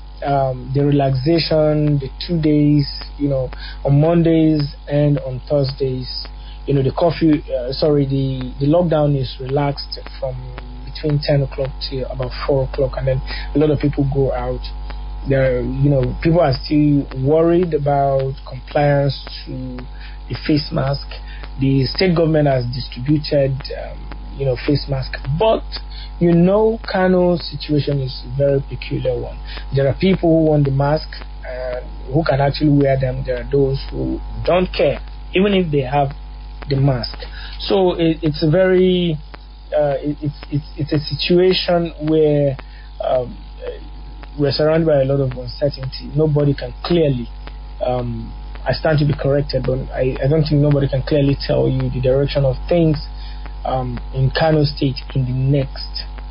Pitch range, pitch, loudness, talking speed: 130-150 Hz, 140 Hz, -18 LUFS, 160 wpm